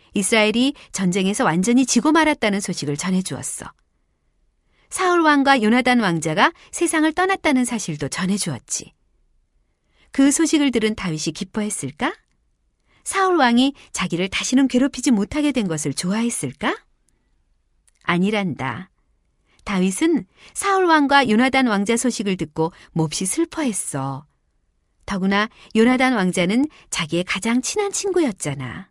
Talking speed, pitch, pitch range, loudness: 285 characters per minute, 215 Hz, 175-275 Hz, -20 LUFS